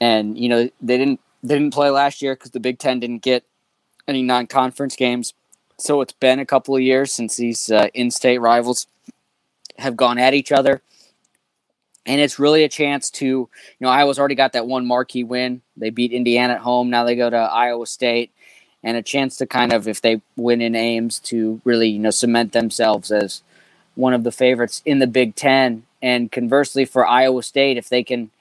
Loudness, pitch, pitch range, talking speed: -18 LUFS, 125 Hz, 120-135 Hz, 205 wpm